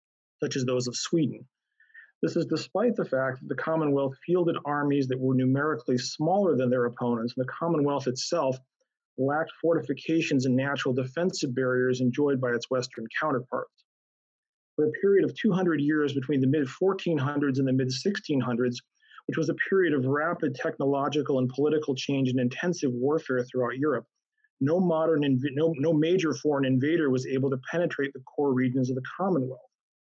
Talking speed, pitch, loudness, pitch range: 165 wpm, 140 Hz, -27 LUFS, 130-160 Hz